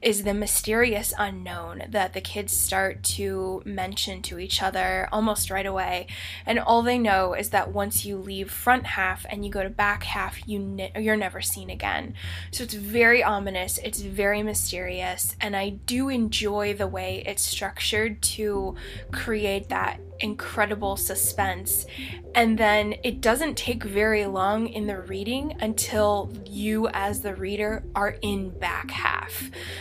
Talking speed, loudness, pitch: 155 wpm, -25 LUFS, 195 Hz